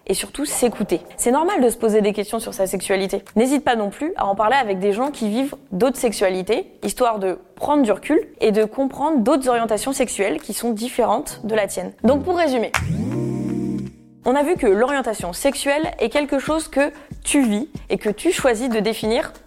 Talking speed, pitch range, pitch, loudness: 200 wpm, 210-275 Hz, 235 Hz, -20 LUFS